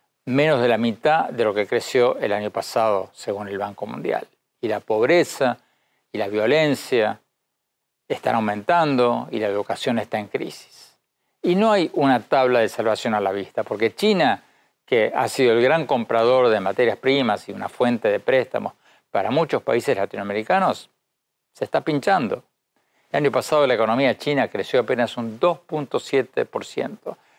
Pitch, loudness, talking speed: 130 Hz, -21 LUFS, 160 wpm